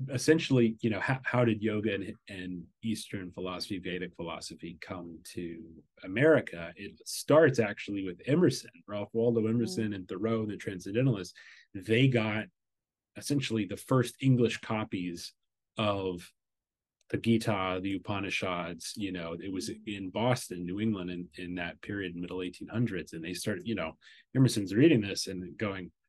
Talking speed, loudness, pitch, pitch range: 150 wpm, -31 LUFS, 100 Hz, 90-115 Hz